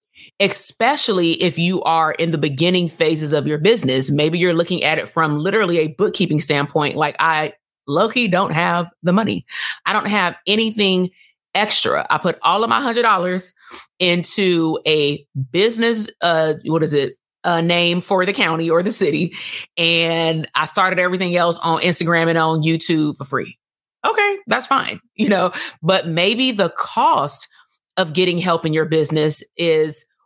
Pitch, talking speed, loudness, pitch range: 170 Hz, 165 wpm, -17 LUFS, 160-190 Hz